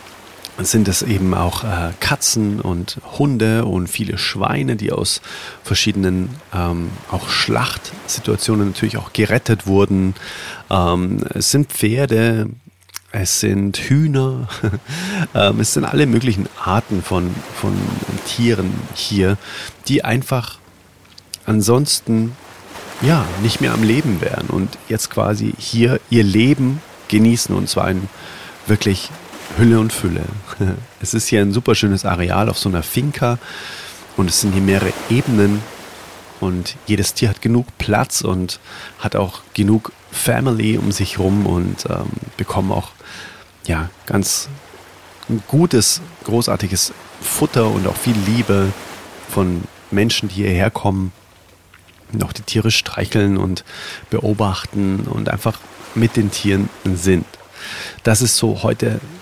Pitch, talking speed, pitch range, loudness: 105 Hz, 130 wpm, 95-115 Hz, -18 LUFS